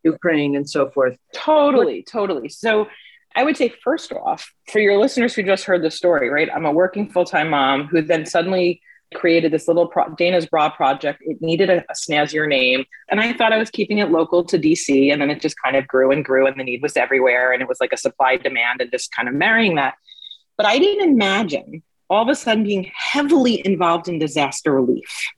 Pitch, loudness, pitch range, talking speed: 170 Hz, -18 LUFS, 150-215 Hz, 220 wpm